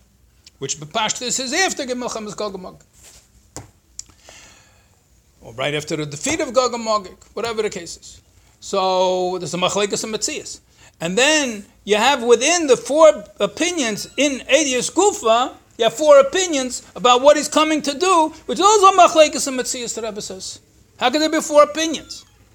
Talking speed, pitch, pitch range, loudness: 160 wpm, 245 Hz, 200-295 Hz, -17 LUFS